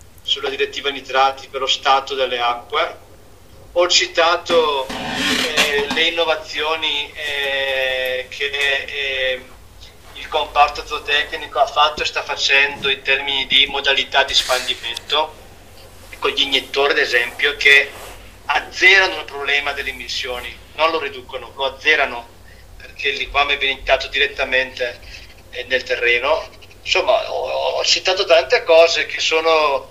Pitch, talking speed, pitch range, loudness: 140 Hz, 125 wpm, 130-160 Hz, -17 LUFS